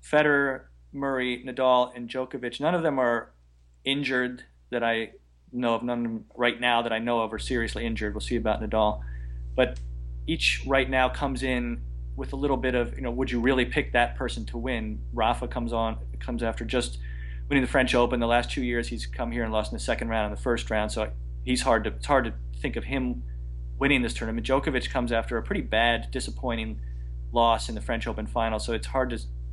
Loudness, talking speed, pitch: -27 LUFS, 220 wpm, 115 Hz